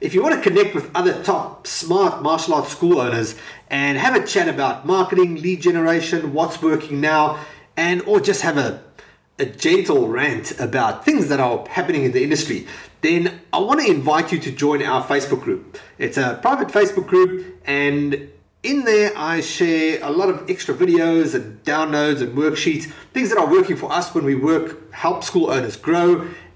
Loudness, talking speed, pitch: -19 LUFS, 190 wpm, 170 Hz